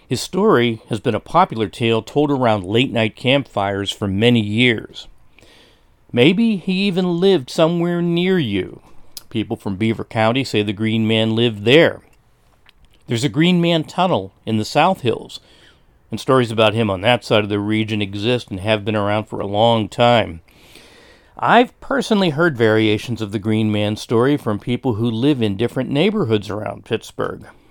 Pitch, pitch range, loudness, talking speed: 115 Hz, 105-145 Hz, -18 LUFS, 170 wpm